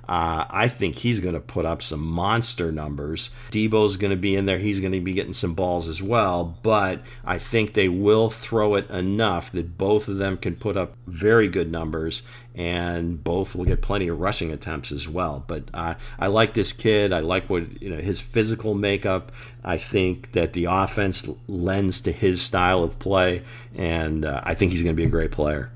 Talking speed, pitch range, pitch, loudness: 210 wpm, 85-110 Hz, 95 Hz, -23 LUFS